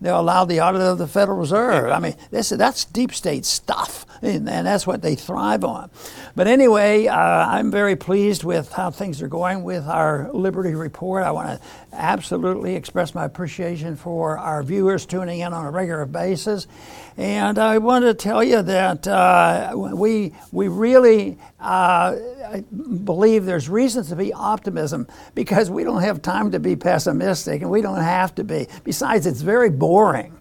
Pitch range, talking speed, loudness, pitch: 175-210 Hz, 175 wpm, -19 LUFS, 190 Hz